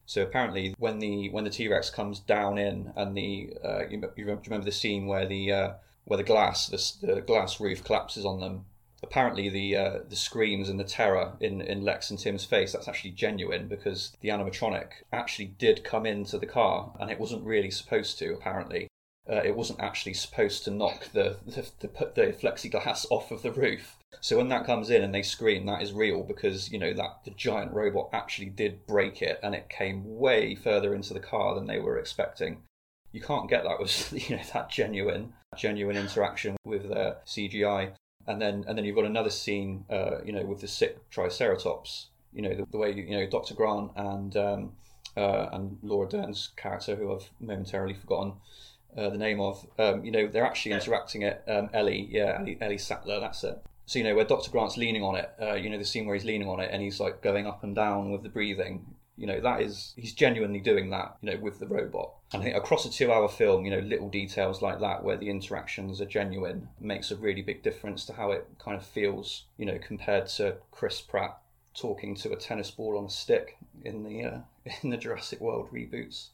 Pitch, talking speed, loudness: 105 Hz, 215 wpm, -30 LUFS